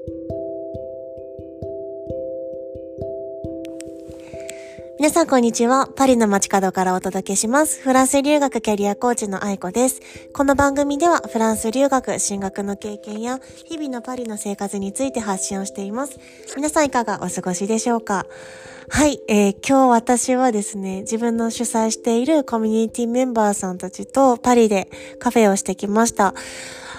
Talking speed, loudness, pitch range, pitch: 310 characters per minute, -19 LUFS, 185-250 Hz, 215 Hz